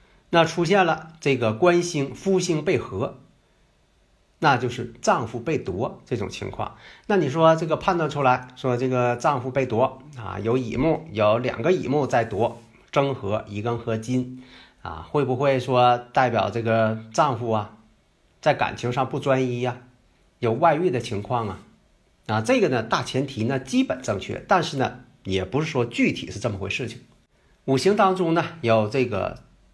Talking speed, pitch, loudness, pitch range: 240 characters per minute, 130 Hz, -23 LUFS, 115-150 Hz